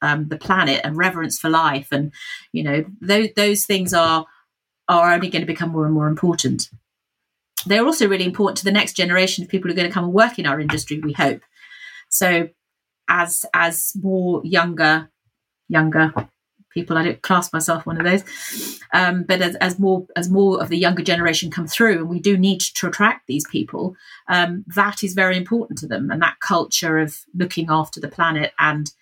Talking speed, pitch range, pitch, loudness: 200 wpm, 160-190 Hz, 175 Hz, -19 LUFS